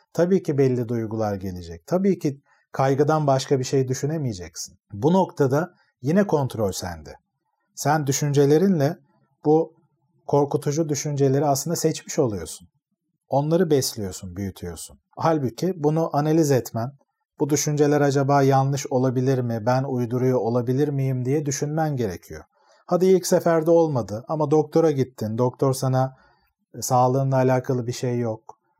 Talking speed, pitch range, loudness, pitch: 125 wpm, 125-155 Hz, -22 LUFS, 140 Hz